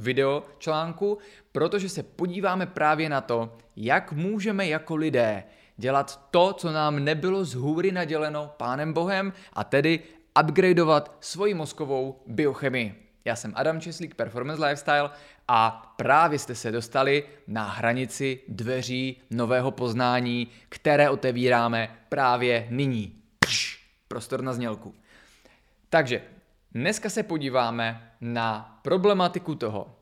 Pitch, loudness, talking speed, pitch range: 140 Hz, -26 LUFS, 115 wpm, 120-160 Hz